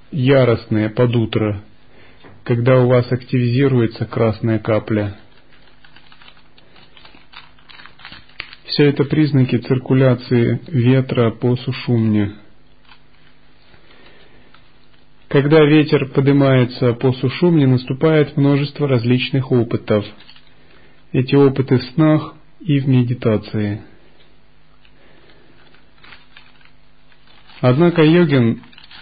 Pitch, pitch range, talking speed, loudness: 125 Hz, 115-140 Hz, 70 wpm, -16 LUFS